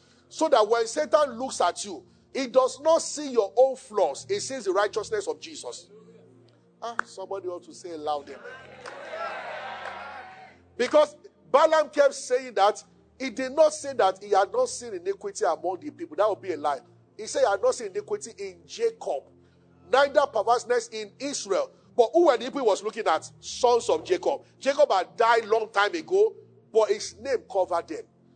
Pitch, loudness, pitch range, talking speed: 265 Hz, -26 LUFS, 210-325 Hz, 185 wpm